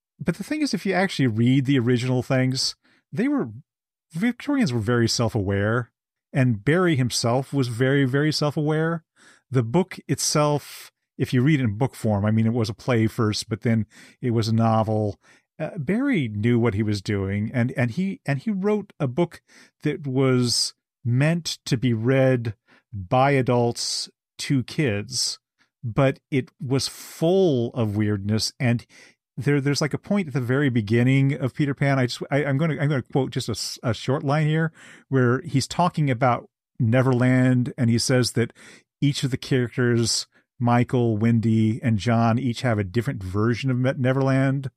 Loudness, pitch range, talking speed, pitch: -23 LUFS, 115-145 Hz, 175 wpm, 130 Hz